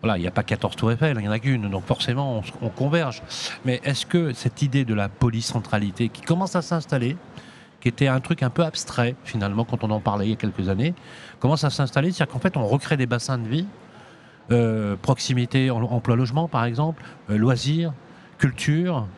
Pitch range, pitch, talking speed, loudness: 115-150 Hz, 130 Hz, 205 wpm, -24 LUFS